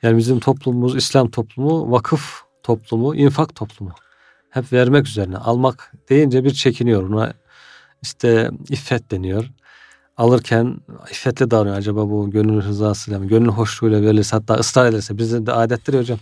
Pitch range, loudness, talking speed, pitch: 110-130 Hz, -17 LUFS, 140 wpm, 115 Hz